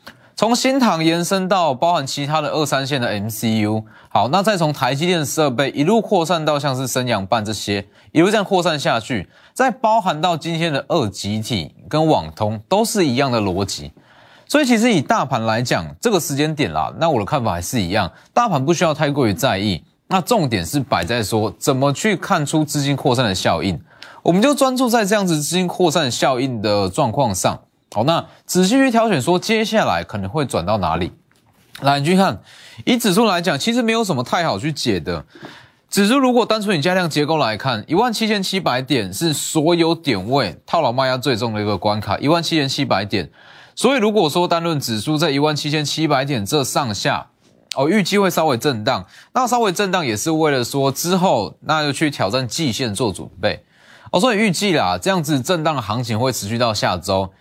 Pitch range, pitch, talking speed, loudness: 120-185 Hz, 150 Hz, 305 characters per minute, -18 LUFS